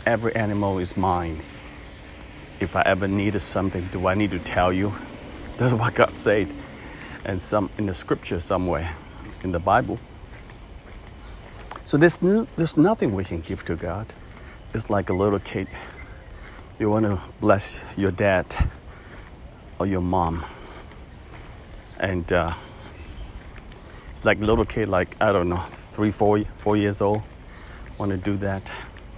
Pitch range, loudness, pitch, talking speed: 90-105 Hz, -23 LUFS, 95 Hz, 145 wpm